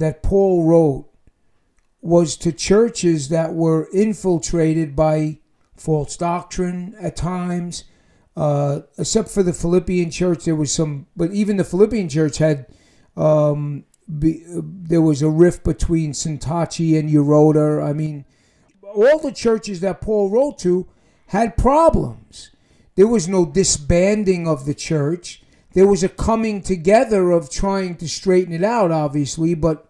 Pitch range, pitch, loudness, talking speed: 155-190 Hz, 170 Hz, -18 LUFS, 145 wpm